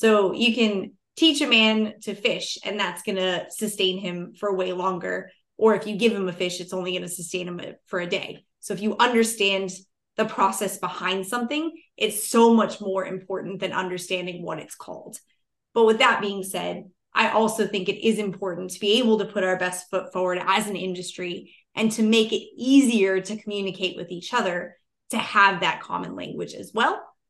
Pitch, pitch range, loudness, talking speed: 195 Hz, 185-220 Hz, -23 LUFS, 200 wpm